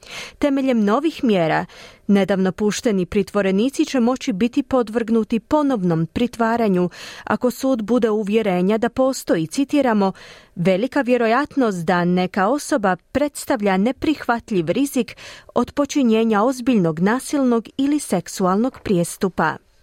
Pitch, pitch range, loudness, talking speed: 230 Hz, 195-260 Hz, -19 LUFS, 105 wpm